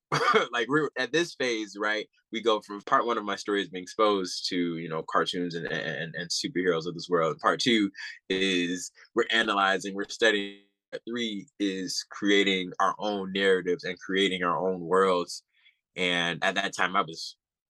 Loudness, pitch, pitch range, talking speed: -27 LUFS, 95 Hz, 90-105 Hz, 175 wpm